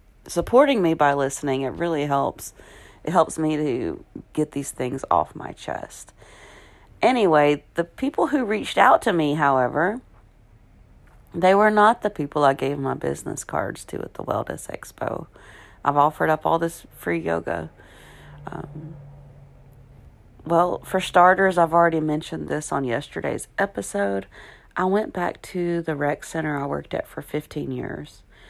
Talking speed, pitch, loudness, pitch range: 150 wpm, 150 Hz, -22 LUFS, 140-170 Hz